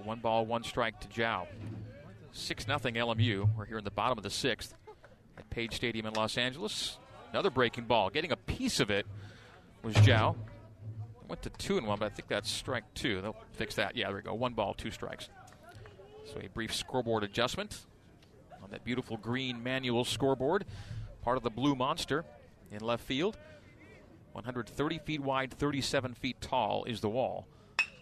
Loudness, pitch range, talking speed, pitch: -34 LUFS, 105-125 Hz, 180 wpm, 115 Hz